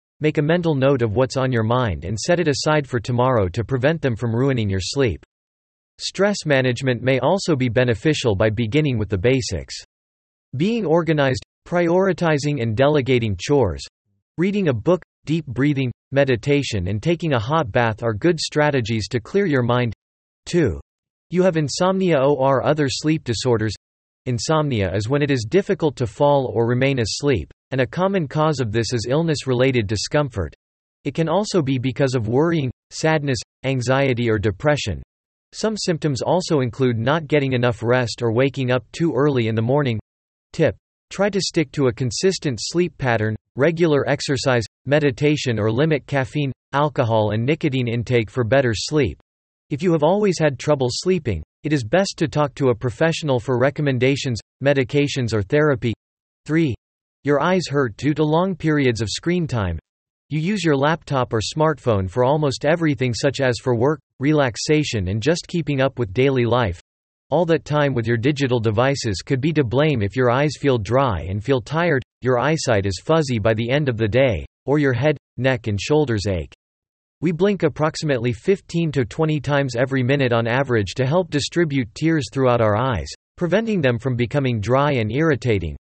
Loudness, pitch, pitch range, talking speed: -20 LUFS, 135 Hz, 120-155 Hz, 175 wpm